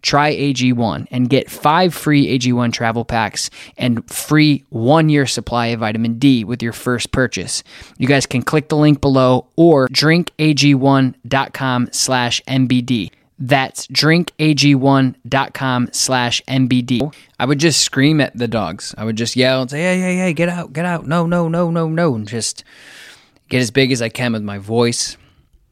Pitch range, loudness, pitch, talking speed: 120-150 Hz, -16 LUFS, 130 Hz, 155 wpm